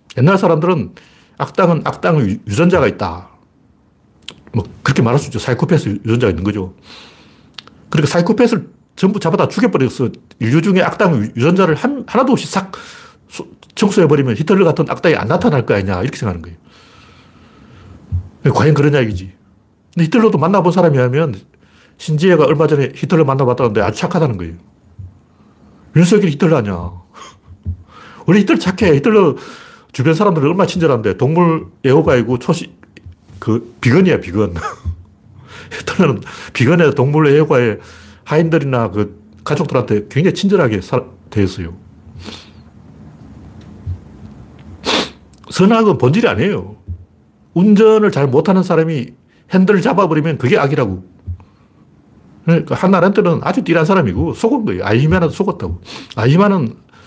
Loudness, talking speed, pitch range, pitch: -14 LUFS, 320 characters per minute, 105-175 Hz, 135 Hz